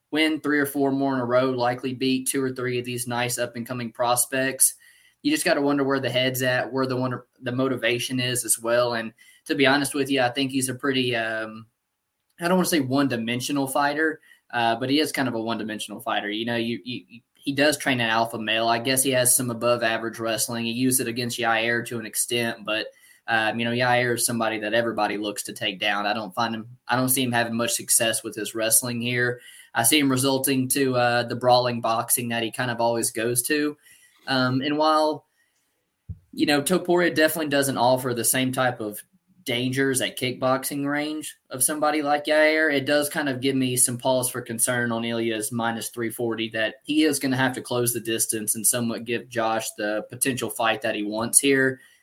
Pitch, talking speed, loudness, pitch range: 125 Hz, 215 wpm, -23 LUFS, 115-135 Hz